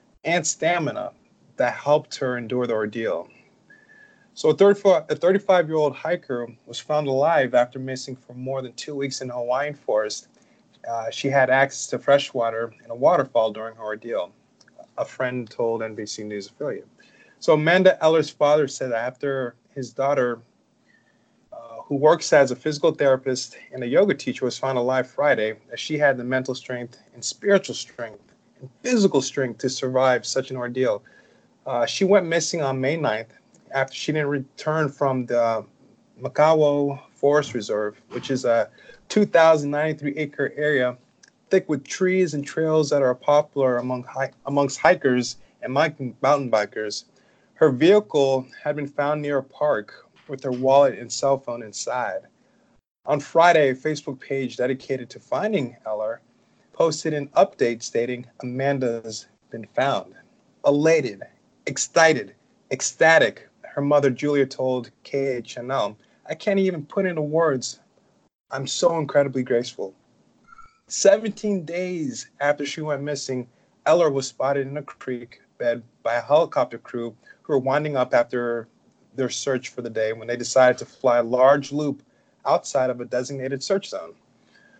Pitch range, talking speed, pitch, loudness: 125-150 Hz, 150 wpm, 135 Hz, -22 LUFS